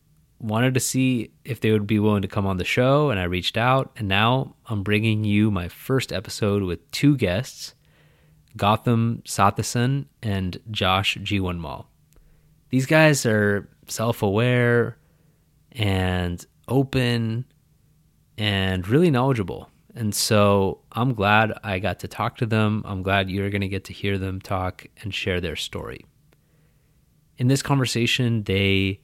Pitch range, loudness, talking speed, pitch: 100-130 Hz, -22 LUFS, 145 wpm, 110 Hz